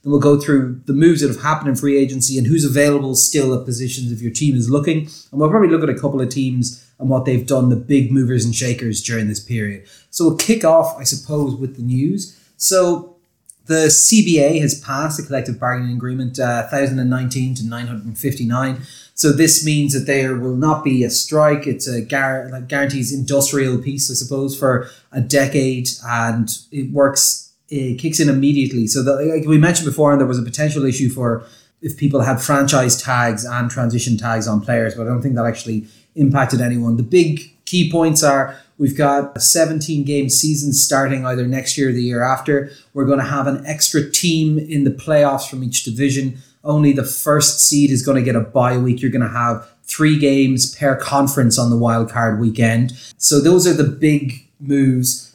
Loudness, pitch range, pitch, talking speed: -16 LUFS, 125-145 Hz, 135 Hz, 200 wpm